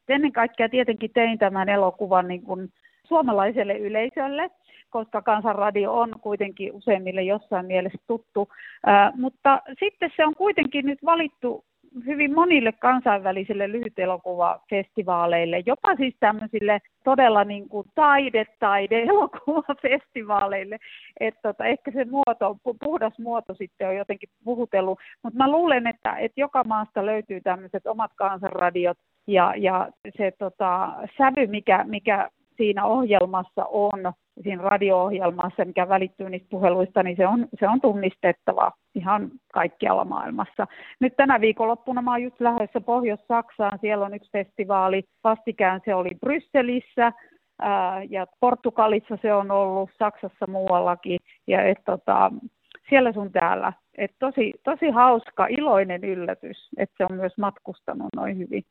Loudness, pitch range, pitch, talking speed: -23 LUFS, 195-250 Hz, 215 Hz, 130 wpm